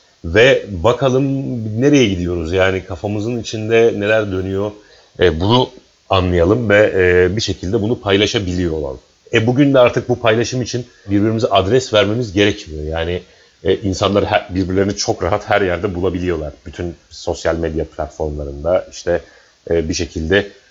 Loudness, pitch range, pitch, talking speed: -16 LUFS, 90-115 Hz, 100 Hz, 140 wpm